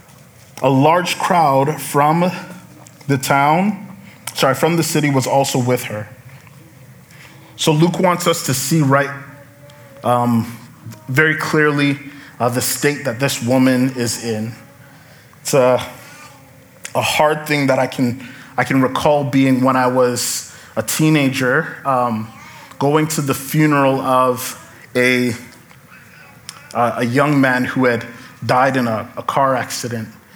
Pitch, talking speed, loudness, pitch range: 135 Hz, 135 wpm, -16 LUFS, 125-145 Hz